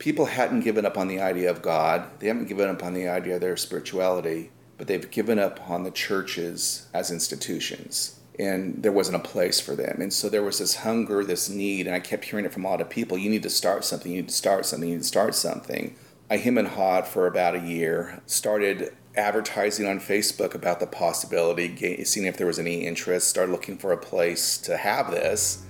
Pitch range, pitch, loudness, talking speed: 90-100 Hz, 95 Hz, -25 LUFS, 225 wpm